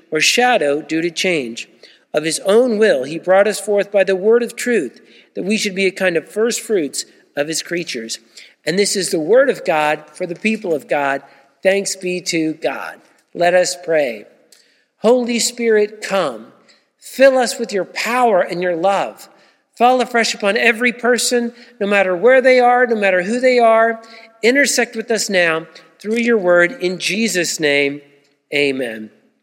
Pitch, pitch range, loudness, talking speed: 195 Hz, 165-235 Hz, -16 LUFS, 175 wpm